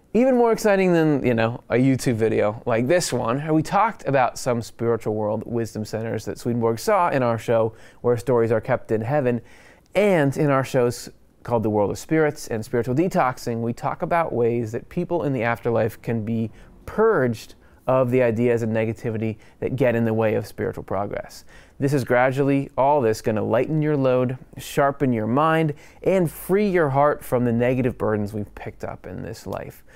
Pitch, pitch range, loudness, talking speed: 125 Hz, 115-150 Hz, -22 LUFS, 190 wpm